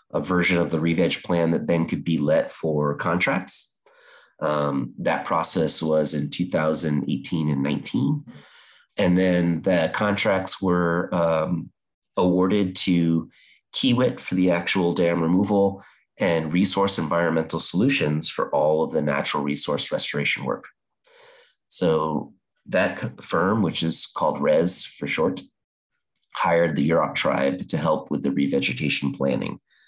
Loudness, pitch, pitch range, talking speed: -23 LUFS, 85 Hz, 75-90 Hz, 135 wpm